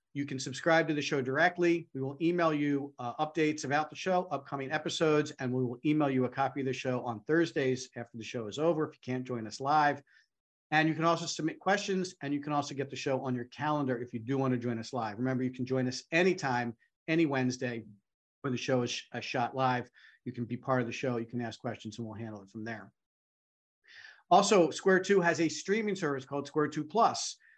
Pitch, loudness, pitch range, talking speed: 135 Hz, -31 LUFS, 125-155 Hz, 235 wpm